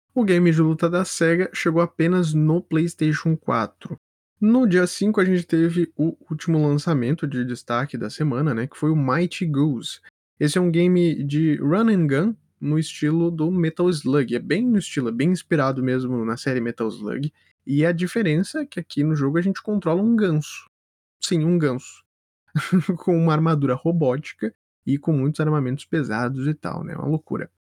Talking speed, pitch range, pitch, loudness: 185 wpm, 140-175 Hz, 160 Hz, -22 LUFS